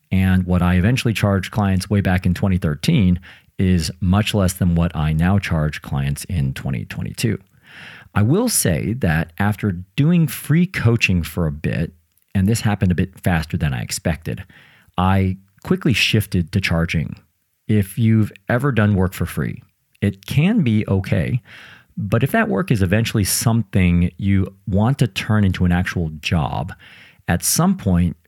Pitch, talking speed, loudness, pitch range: 95 Hz, 160 wpm, -19 LUFS, 90-110 Hz